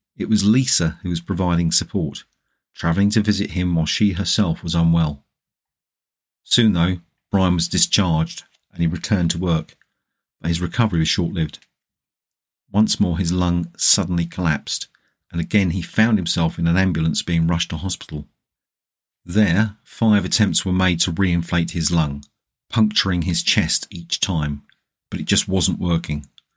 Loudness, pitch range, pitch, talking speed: -20 LUFS, 80-95 Hz, 85 Hz, 155 wpm